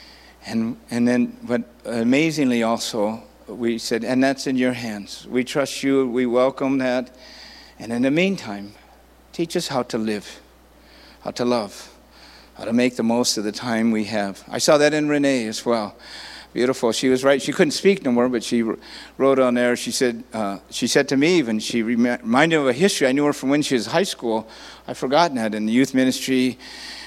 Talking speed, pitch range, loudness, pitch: 205 wpm, 115-135 Hz, -21 LUFS, 125 Hz